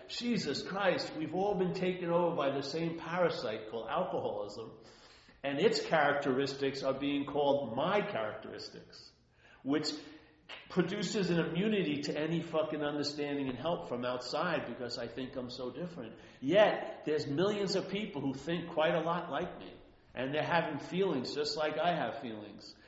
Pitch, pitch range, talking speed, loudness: 155 Hz, 140-180 Hz, 155 wpm, -34 LUFS